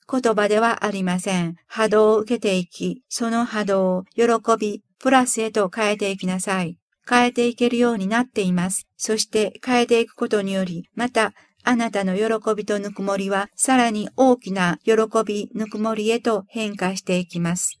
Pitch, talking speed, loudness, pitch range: 215 Hz, 340 characters per minute, -21 LUFS, 195-230 Hz